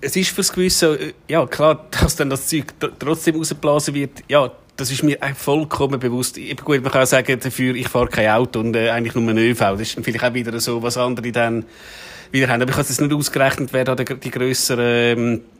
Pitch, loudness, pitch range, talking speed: 130 Hz, -18 LUFS, 120-145 Hz, 225 wpm